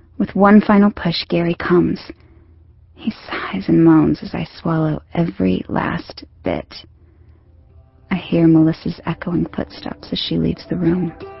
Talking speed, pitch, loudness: 135 wpm, 165 Hz, -18 LUFS